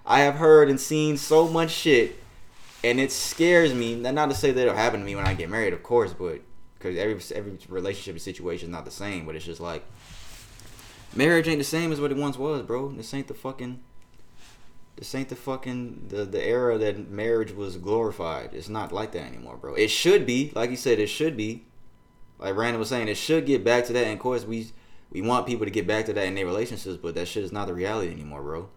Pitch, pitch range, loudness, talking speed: 125 Hz, 110-145 Hz, -25 LUFS, 240 wpm